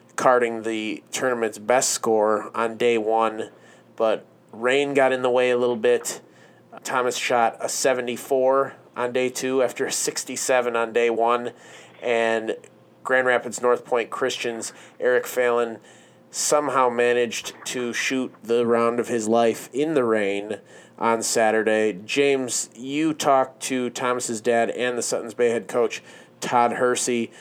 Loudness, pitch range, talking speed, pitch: -22 LUFS, 115-125 Hz, 150 wpm, 120 Hz